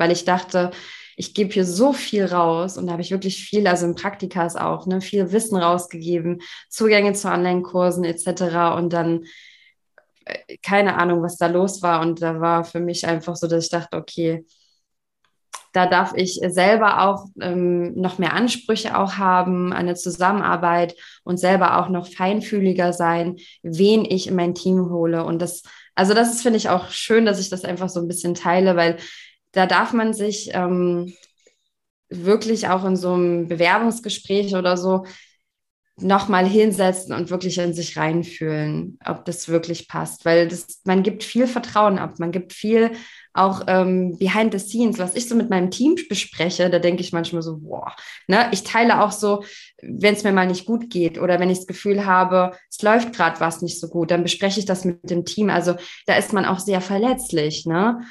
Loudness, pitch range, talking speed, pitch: -20 LUFS, 175-200 Hz, 185 wpm, 185 Hz